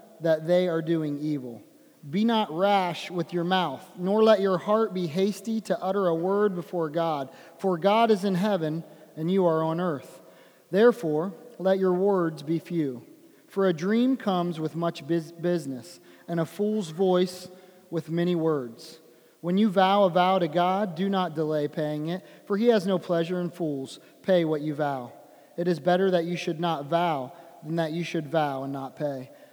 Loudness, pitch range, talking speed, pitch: -26 LUFS, 160-190 Hz, 185 wpm, 175 Hz